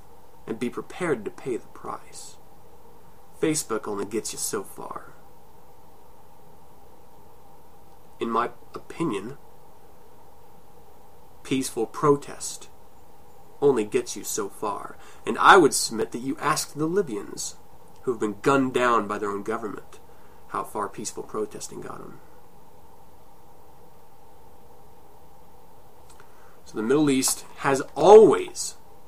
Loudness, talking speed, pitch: -24 LUFS, 110 wpm, 205 Hz